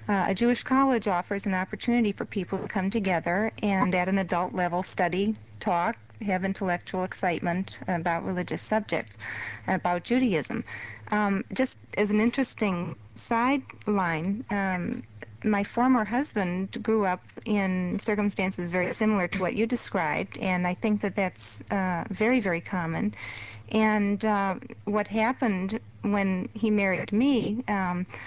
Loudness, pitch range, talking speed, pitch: -28 LUFS, 180-220 Hz, 140 wpm, 200 Hz